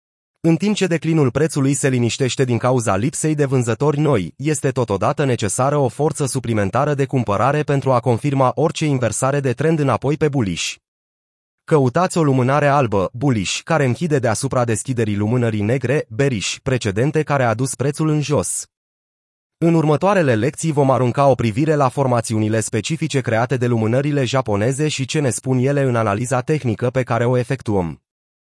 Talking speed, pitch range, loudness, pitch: 160 wpm, 120-145 Hz, -18 LUFS, 135 Hz